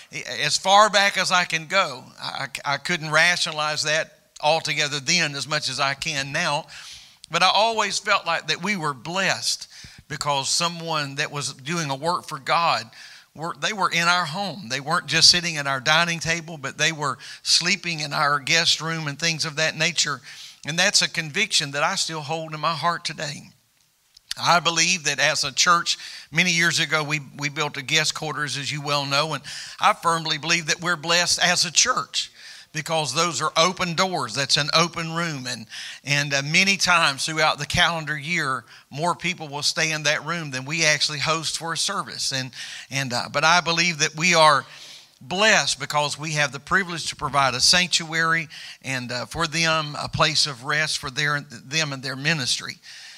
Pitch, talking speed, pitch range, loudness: 155 Hz, 190 wpm, 145-170 Hz, -21 LUFS